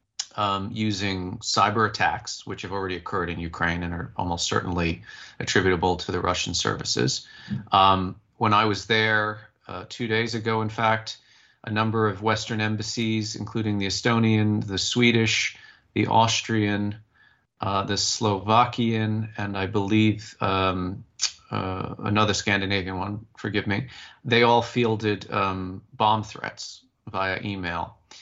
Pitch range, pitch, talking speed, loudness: 95-110 Hz, 105 Hz, 135 wpm, -24 LUFS